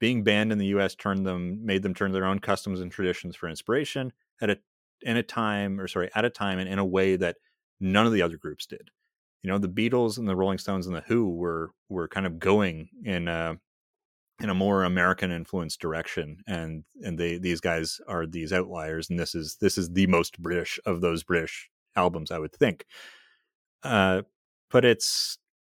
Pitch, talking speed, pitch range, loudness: 95 Hz, 205 wpm, 85-100 Hz, -27 LUFS